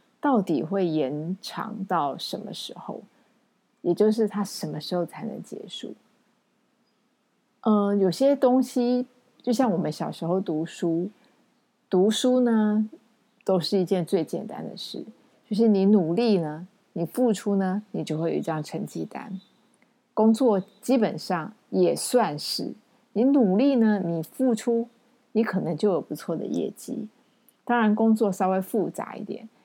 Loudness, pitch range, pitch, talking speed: -25 LUFS, 185-240 Hz, 215 Hz, 210 characters per minute